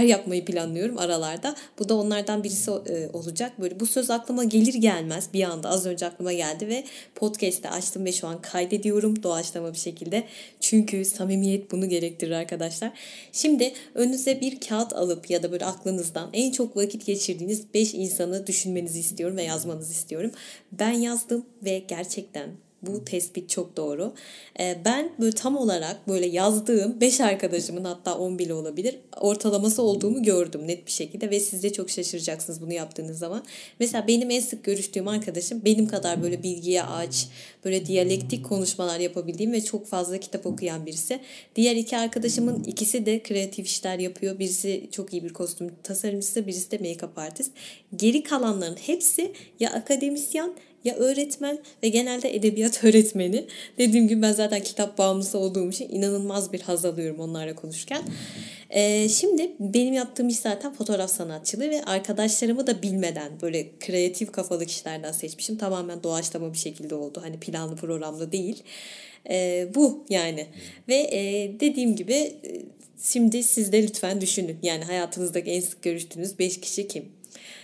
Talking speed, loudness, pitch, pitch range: 155 wpm, -25 LUFS, 195 Hz, 175-225 Hz